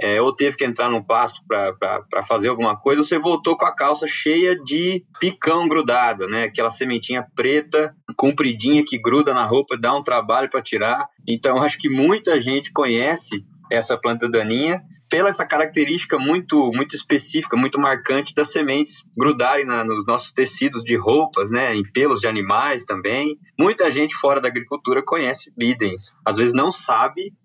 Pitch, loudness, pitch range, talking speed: 145 Hz, -19 LUFS, 125-165 Hz, 170 wpm